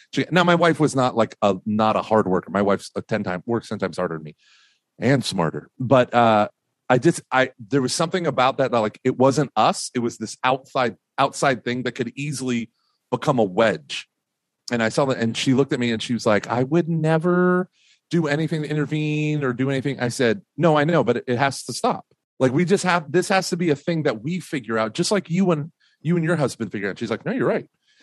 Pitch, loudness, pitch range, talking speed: 130 Hz, -22 LUFS, 115-160 Hz, 245 wpm